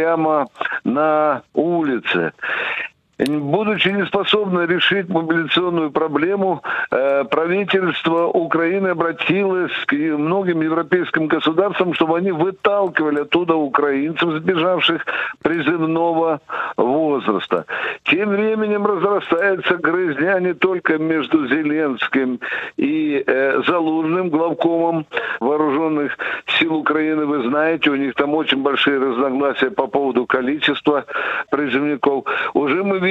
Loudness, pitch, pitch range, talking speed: -18 LUFS, 165 Hz, 155-190 Hz, 95 wpm